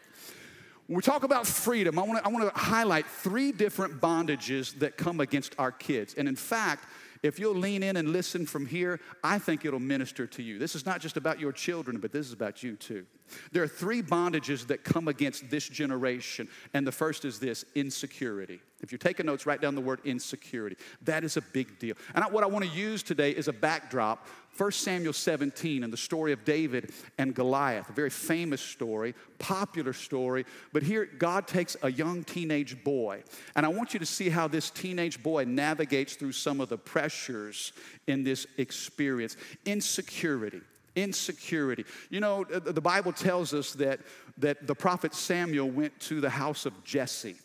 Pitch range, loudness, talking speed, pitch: 135-175 Hz, -31 LUFS, 190 wpm, 150 Hz